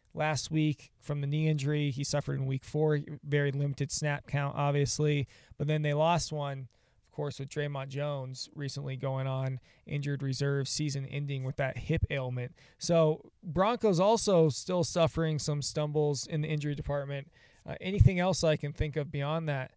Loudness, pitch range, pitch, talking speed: -31 LUFS, 135-155 Hz, 145 Hz, 175 wpm